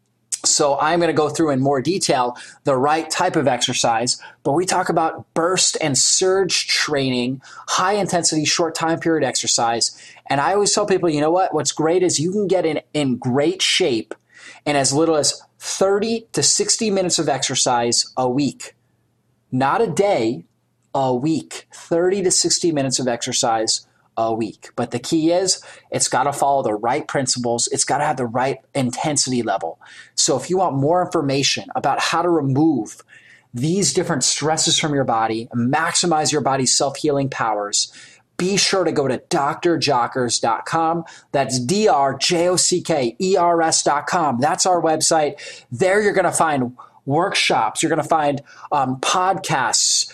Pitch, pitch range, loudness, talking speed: 155 Hz, 130-175 Hz, -18 LUFS, 170 wpm